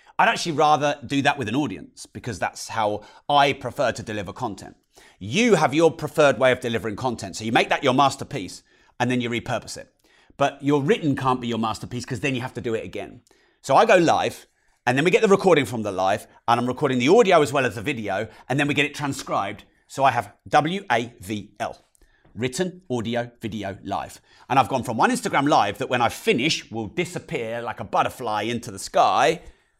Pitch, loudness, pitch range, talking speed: 130 Hz, -22 LUFS, 115-150 Hz, 220 wpm